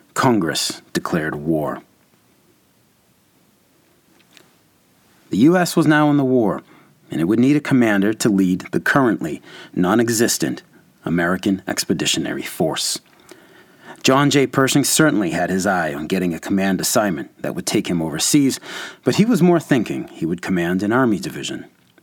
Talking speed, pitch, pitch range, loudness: 145 wpm, 125 Hz, 95-145 Hz, -18 LUFS